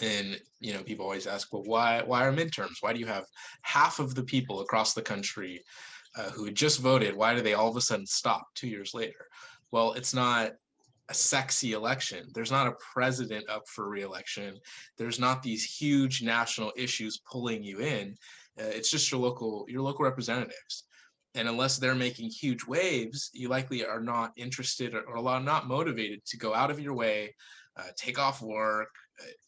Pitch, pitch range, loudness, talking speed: 120 Hz, 110-130 Hz, -30 LUFS, 190 wpm